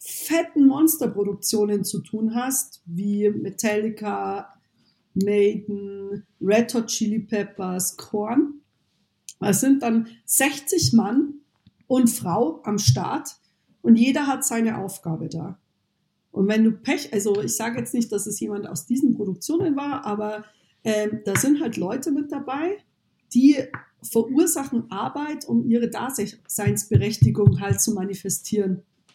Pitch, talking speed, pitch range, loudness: 220 Hz, 125 wpm, 200-265 Hz, -23 LUFS